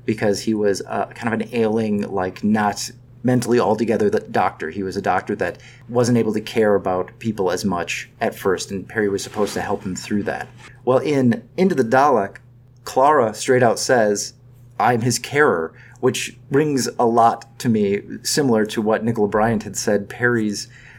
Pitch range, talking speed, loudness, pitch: 105-125 Hz, 180 wpm, -20 LUFS, 115 Hz